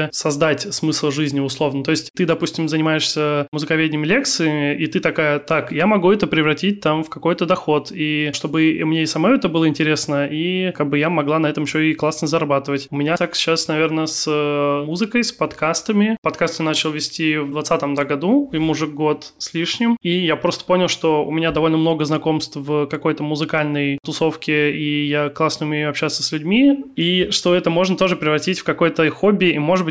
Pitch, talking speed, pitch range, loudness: 155 Hz, 190 wpm, 150-170 Hz, -18 LUFS